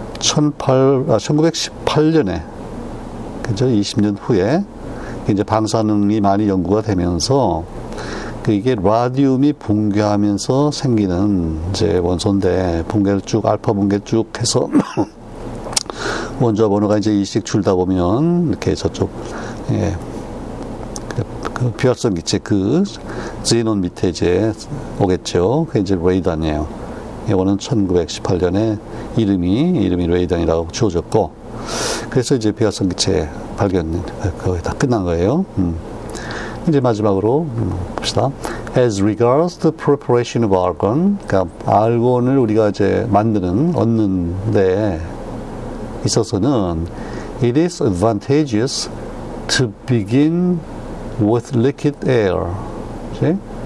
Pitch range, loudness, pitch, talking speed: 100-125 Hz, -17 LUFS, 110 Hz, 280 characters per minute